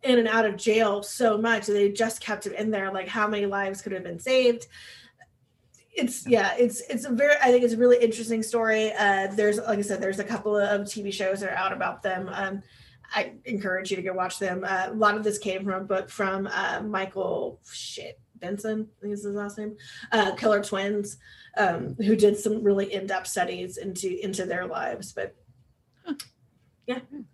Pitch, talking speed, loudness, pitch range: 205 Hz, 210 wpm, -26 LUFS, 195-225 Hz